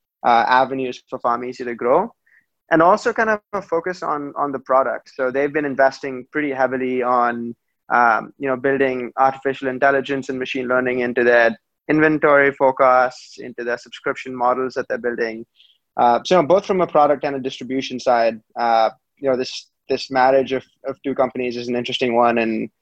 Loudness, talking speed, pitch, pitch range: -19 LUFS, 185 wpm, 130 Hz, 120-140 Hz